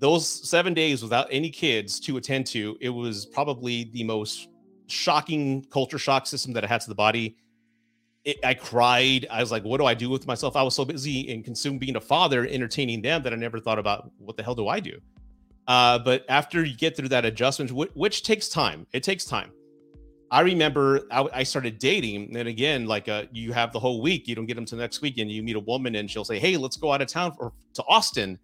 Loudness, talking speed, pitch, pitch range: -25 LUFS, 240 wpm, 125 Hz, 115-140 Hz